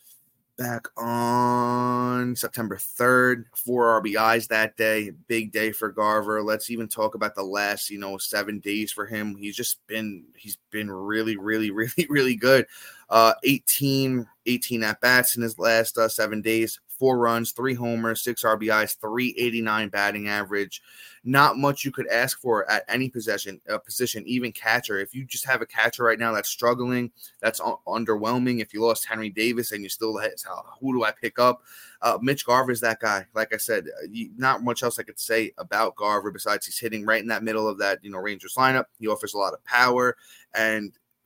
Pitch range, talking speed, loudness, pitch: 110-125 Hz, 195 wpm, -24 LUFS, 115 Hz